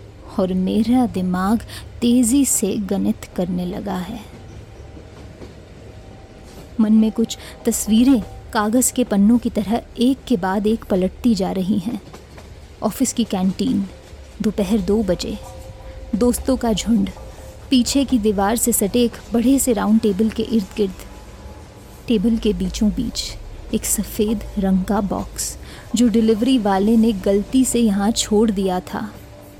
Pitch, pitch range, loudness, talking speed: 215 Hz, 195-235 Hz, -19 LUFS, 135 wpm